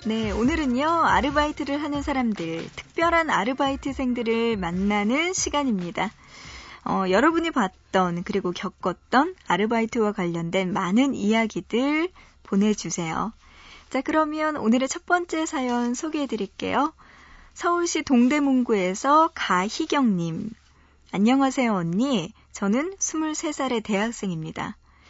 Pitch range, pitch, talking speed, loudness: 200-295 Hz, 240 Hz, 280 characters per minute, -24 LUFS